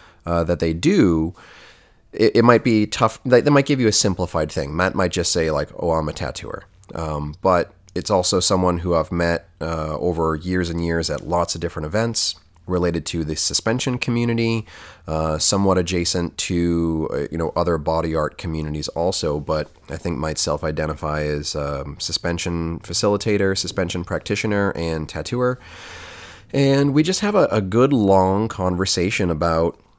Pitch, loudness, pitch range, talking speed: 85 Hz, -20 LUFS, 80-100 Hz, 165 wpm